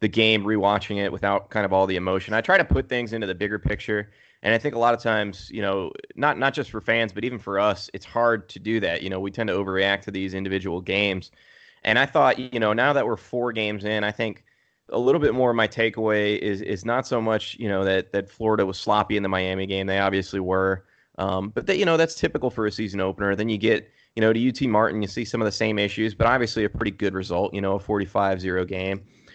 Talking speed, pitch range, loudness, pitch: 265 wpm, 95-115 Hz, -24 LUFS, 105 Hz